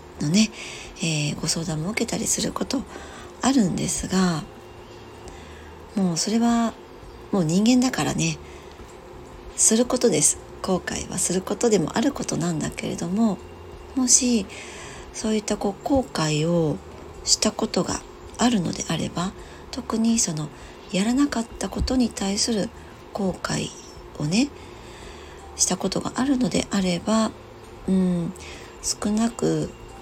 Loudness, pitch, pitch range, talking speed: -23 LUFS, 205 Hz, 175-235 Hz, 245 characters per minute